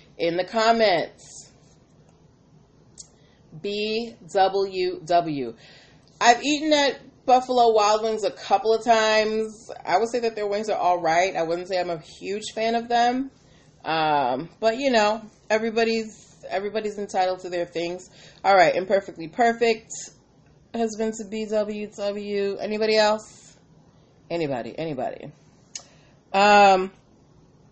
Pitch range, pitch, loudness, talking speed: 170-220 Hz, 205 Hz, -23 LUFS, 130 wpm